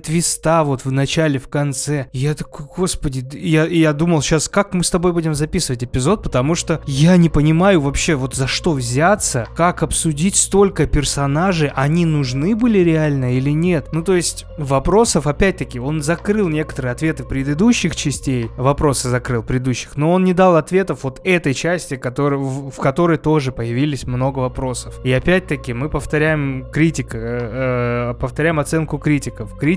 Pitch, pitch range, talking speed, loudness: 150 Hz, 130-165 Hz, 160 wpm, -17 LUFS